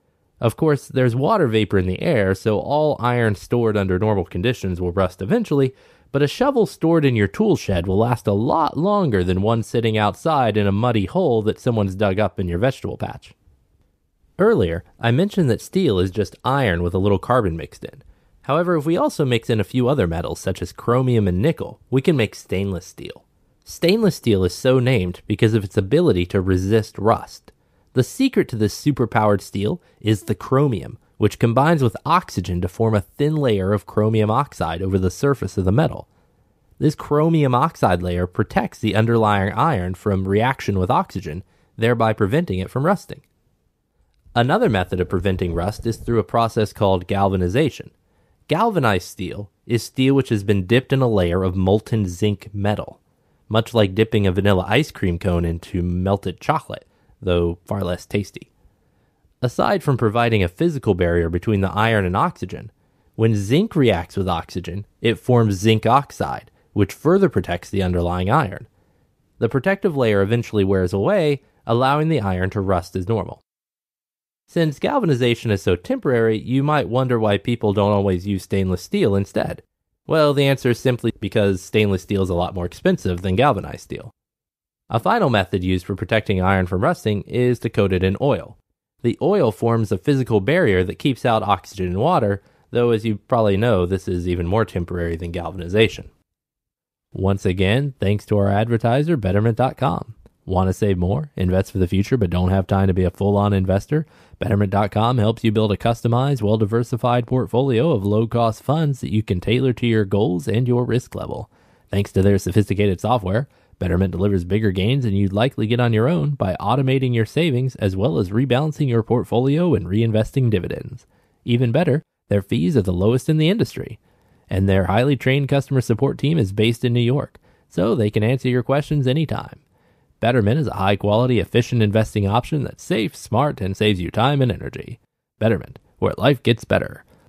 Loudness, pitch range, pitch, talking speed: -20 LUFS, 95-125 Hz, 110 Hz, 185 wpm